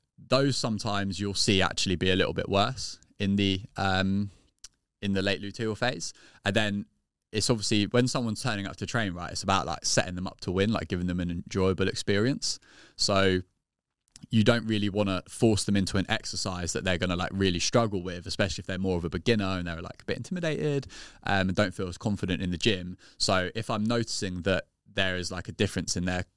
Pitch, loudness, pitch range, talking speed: 100 Hz, -28 LUFS, 95-110 Hz, 220 wpm